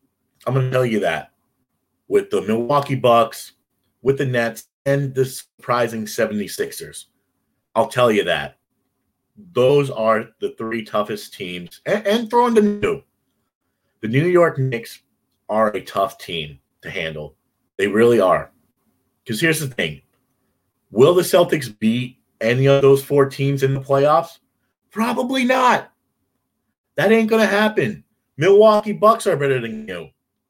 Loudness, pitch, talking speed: -18 LUFS, 140 Hz, 145 wpm